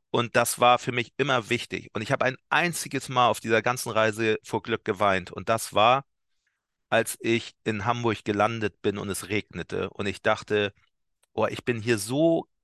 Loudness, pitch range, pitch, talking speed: -26 LUFS, 105-125 Hz, 115 Hz, 190 wpm